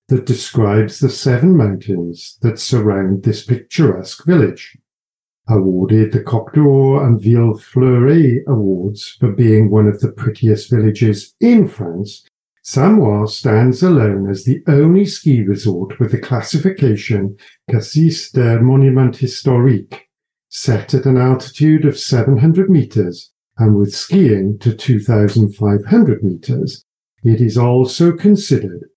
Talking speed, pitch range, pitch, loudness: 120 wpm, 105-135 Hz, 125 Hz, -14 LUFS